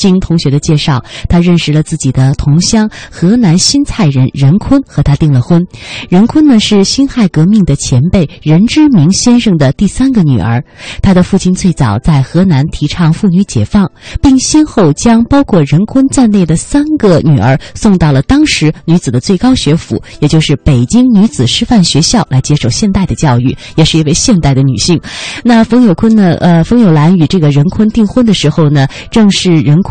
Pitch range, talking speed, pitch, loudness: 145-215 Hz, 285 characters per minute, 170 Hz, -8 LUFS